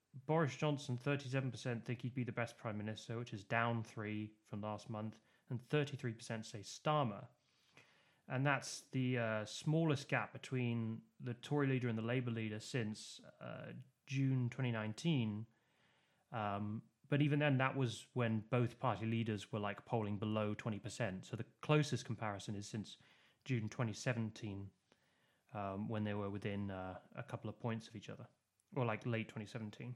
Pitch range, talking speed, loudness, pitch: 110-130 Hz, 160 wpm, -41 LUFS, 115 Hz